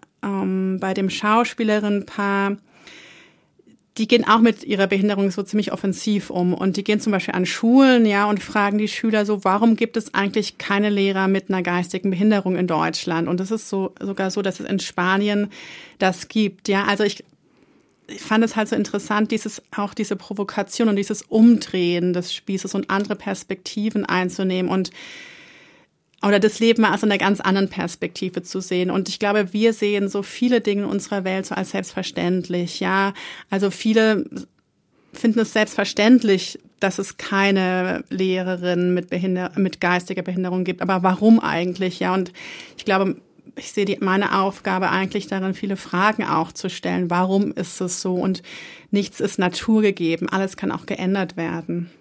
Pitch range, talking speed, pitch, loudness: 185-210 Hz, 170 wpm, 195 Hz, -21 LUFS